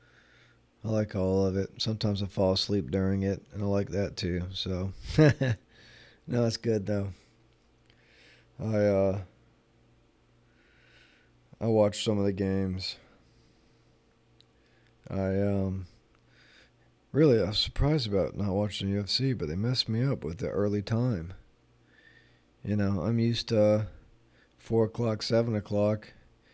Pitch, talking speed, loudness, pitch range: 110 Hz, 130 wpm, -29 LUFS, 100-115 Hz